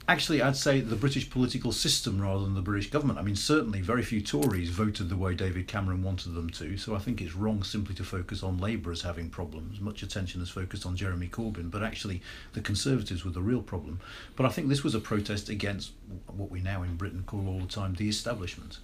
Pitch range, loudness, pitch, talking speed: 95-110 Hz, -31 LUFS, 100 Hz, 235 wpm